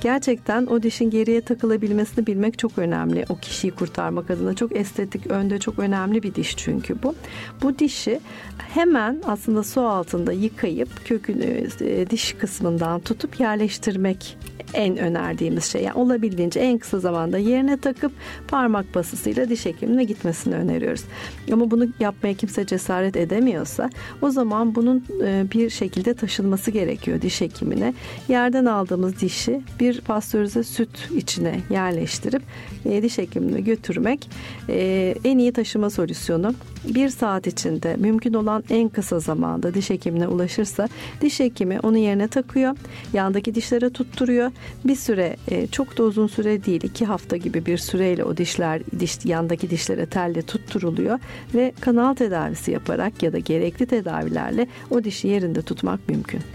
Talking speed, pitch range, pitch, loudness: 140 wpm, 190-240 Hz, 220 Hz, -22 LUFS